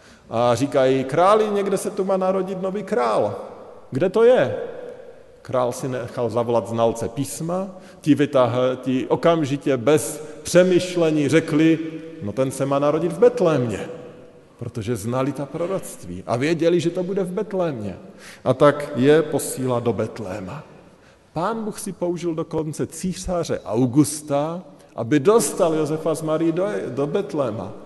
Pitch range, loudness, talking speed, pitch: 130-185 Hz, -21 LUFS, 140 wpm, 155 Hz